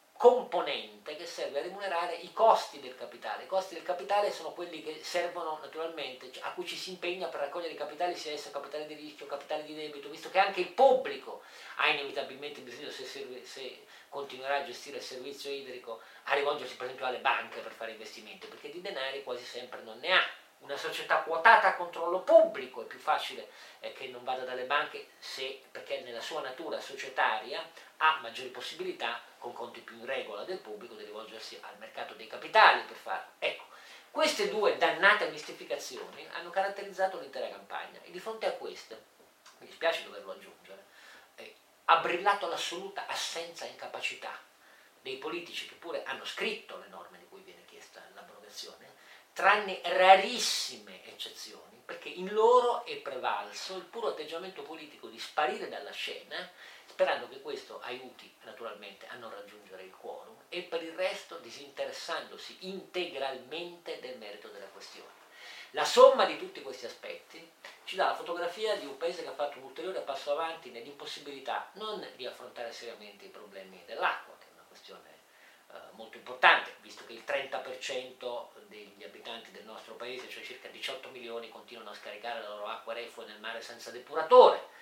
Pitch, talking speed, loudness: 185 Hz, 170 wpm, -31 LUFS